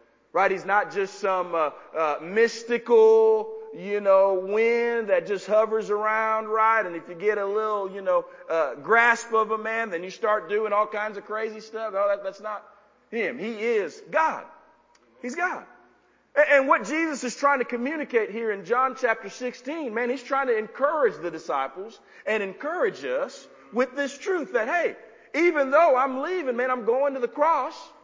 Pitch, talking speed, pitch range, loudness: 230 Hz, 185 wpm, 210-285 Hz, -24 LUFS